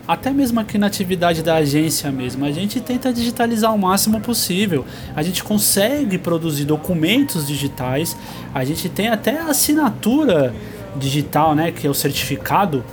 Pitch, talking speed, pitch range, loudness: 175 Hz, 150 wpm, 145-220 Hz, -18 LUFS